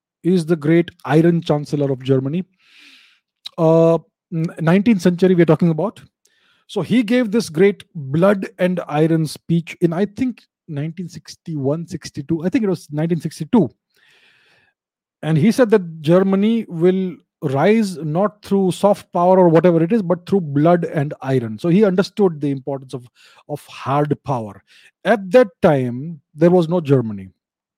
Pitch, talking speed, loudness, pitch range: 170 Hz, 150 wpm, -17 LUFS, 150-195 Hz